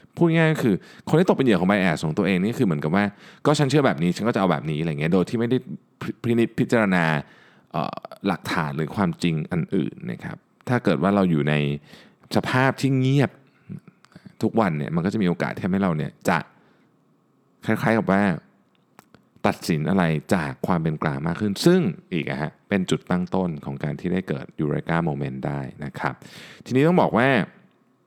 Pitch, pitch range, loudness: 100 Hz, 85-135 Hz, -23 LUFS